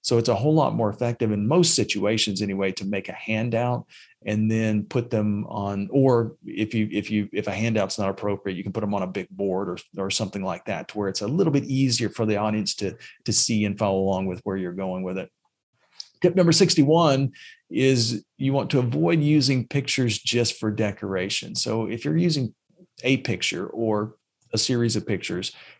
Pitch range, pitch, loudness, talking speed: 100-130 Hz, 110 Hz, -24 LUFS, 205 wpm